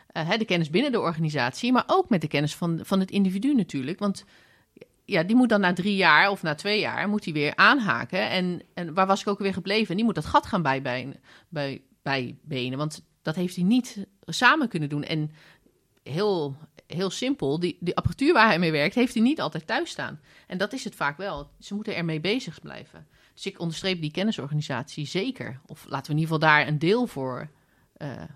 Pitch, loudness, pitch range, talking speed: 175 Hz, -25 LUFS, 150-205 Hz, 215 wpm